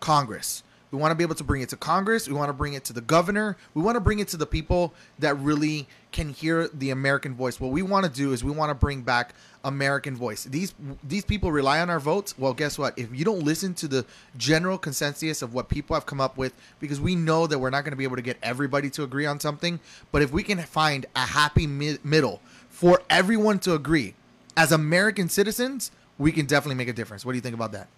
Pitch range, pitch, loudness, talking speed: 130-165 Hz, 145 Hz, -25 LUFS, 250 wpm